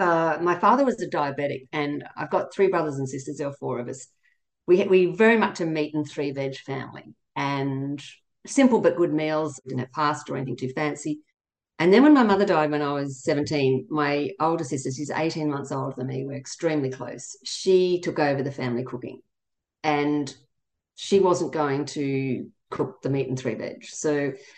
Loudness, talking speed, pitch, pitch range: -24 LUFS, 200 wpm, 145 Hz, 135-170 Hz